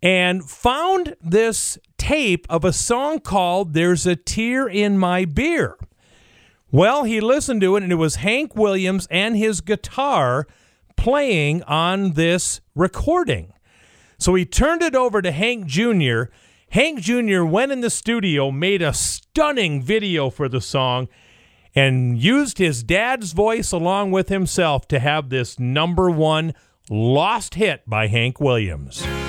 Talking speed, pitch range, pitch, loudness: 145 wpm, 145-220 Hz, 180 Hz, -19 LUFS